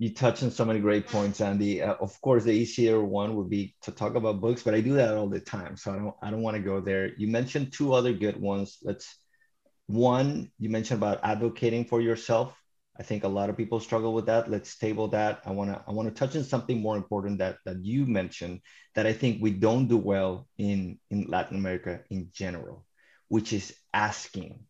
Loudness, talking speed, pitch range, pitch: -28 LUFS, 220 wpm, 100-115 Hz, 110 Hz